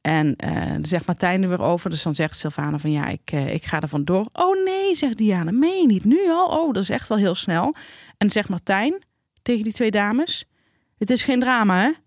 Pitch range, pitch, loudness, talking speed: 170-275 Hz, 205 Hz, -21 LUFS, 240 wpm